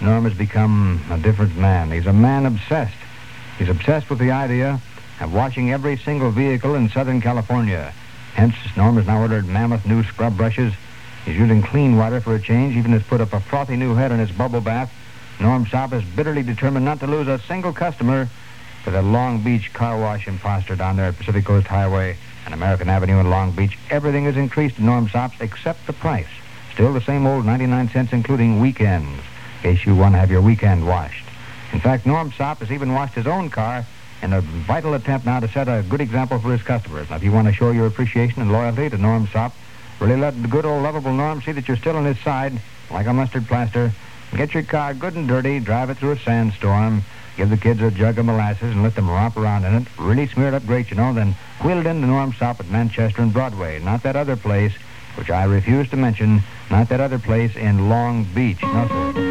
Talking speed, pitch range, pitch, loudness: 225 wpm, 105-130 Hz, 115 Hz, -19 LUFS